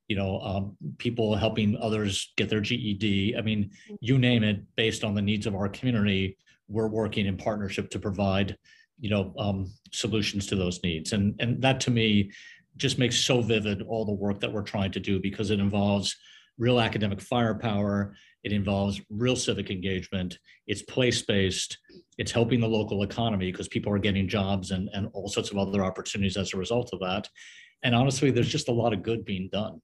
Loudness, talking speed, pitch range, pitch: -28 LUFS, 195 wpm, 100-115 Hz, 105 Hz